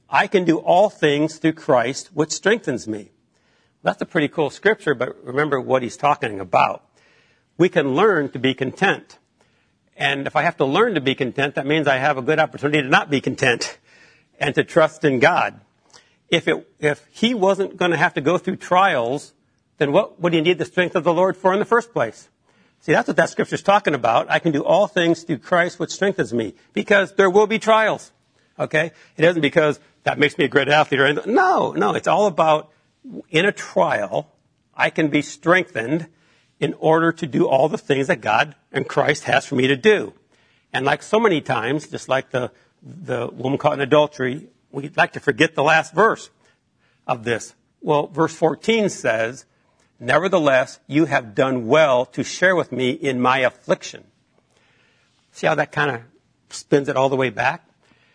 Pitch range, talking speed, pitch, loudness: 135-175 Hz, 195 wpm, 155 Hz, -19 LUFS